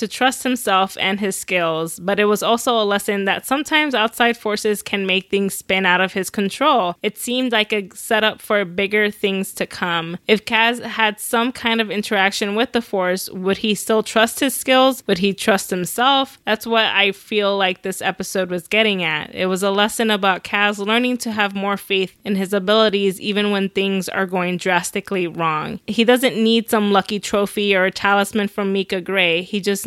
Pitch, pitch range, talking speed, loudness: 205 Hz, 190-220 Hz, 200 wpm, -18 LUFS